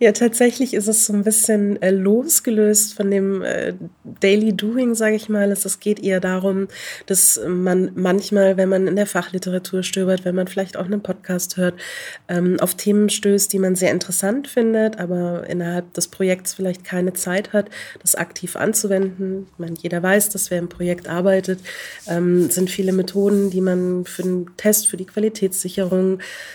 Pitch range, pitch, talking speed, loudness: 180-205 Hz, 190 Hz, 180 wpm, -19 LUFS